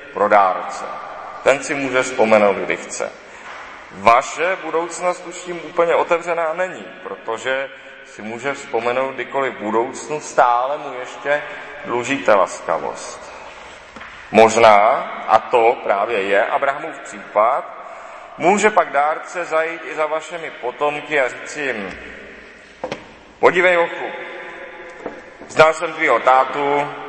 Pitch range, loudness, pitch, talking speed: 130-170 Hz, -18 LUFS, 145 Hz, 110 wpm